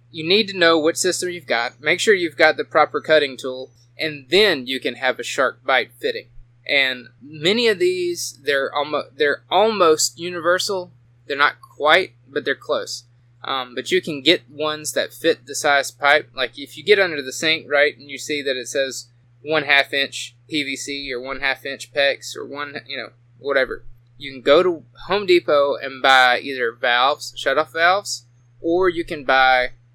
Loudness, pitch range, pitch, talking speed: -19 LUFS, 125-165 Hz, 140 Hz, 190 wpm